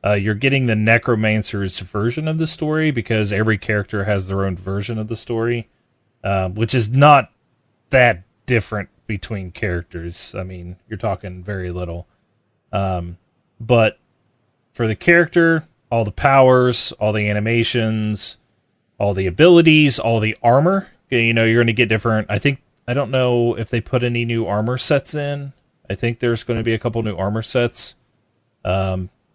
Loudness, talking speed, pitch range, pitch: -18 LUFS, 170 wpm, 105-125 Hz, 115 Hz